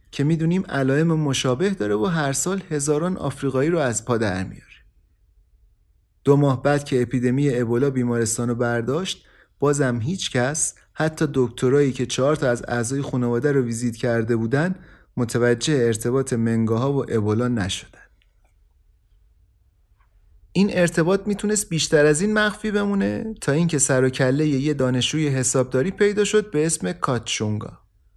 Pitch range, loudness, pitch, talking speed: 115-150 Hz, -21 LUFS, 130 Hz, 140 wpm